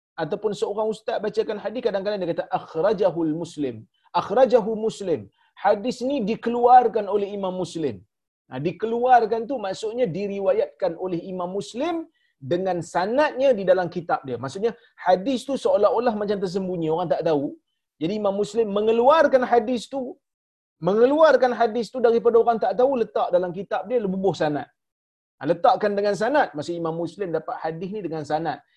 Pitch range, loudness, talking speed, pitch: 175-240 Hz, -23 LUFS, 150 wpm, 205 Hz